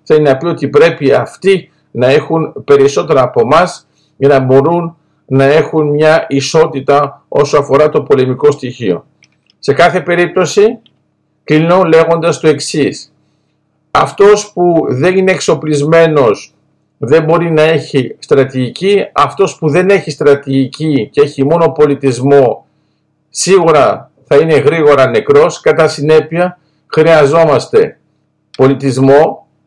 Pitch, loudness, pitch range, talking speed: 155 Hz, -10 LUFS, 145-175 Hz, 115 wpm